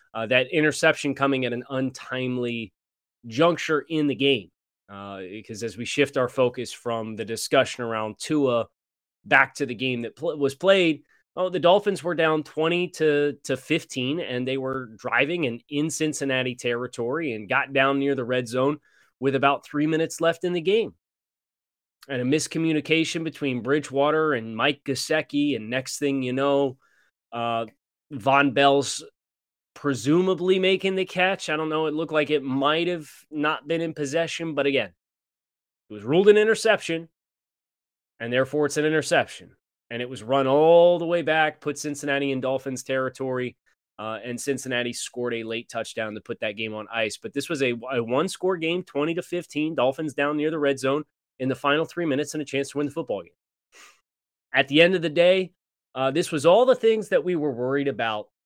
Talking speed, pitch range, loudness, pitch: 185 wpm, 125-160 Hz, -24 LUFS, 140 Hz